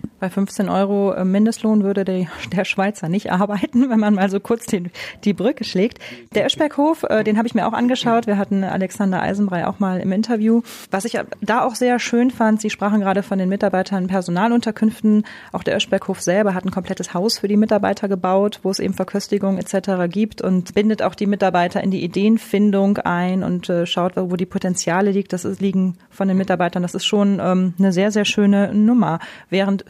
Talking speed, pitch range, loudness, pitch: 200 wpm, 190-215 Hz, -19 LUFS, 200 Hz